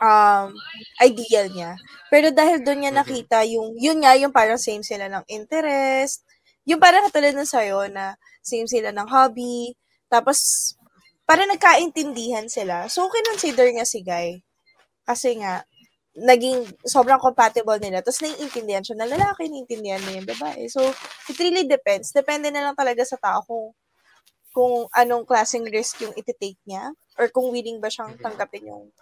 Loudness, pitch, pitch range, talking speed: -20 LUFS, 245 Hz, 215-280 Hz, 155 wpm